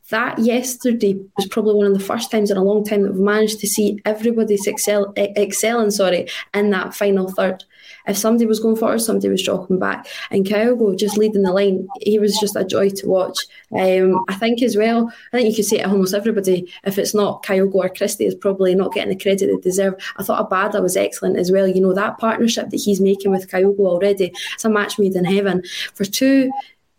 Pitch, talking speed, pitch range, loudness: 205 Hz, 220 wpm, 195-220 Hz, -18 LUFS